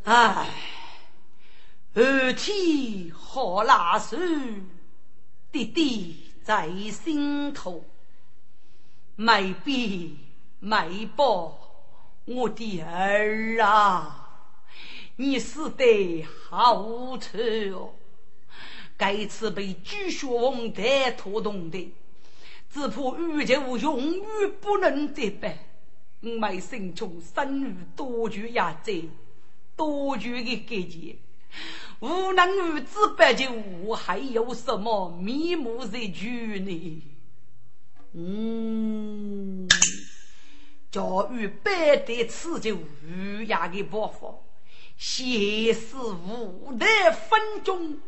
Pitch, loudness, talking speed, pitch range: 225 Hz, -26 LUFS, 115 characters per minute, 190-275 Hz